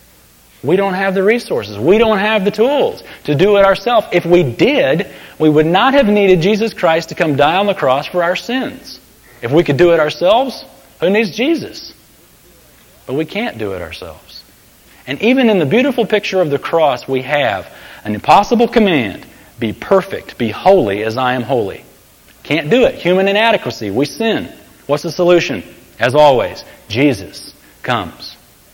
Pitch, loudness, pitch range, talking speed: 185 Hz, -14 LUFS, 150-225 Hz, 175 wpm